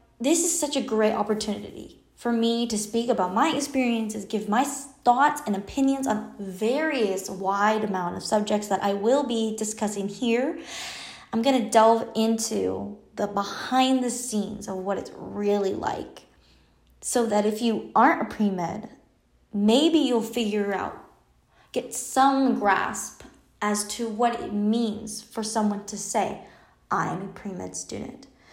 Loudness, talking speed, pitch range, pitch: -25 LUFS, 150 wpm, 205-245 Hz, 220 Hz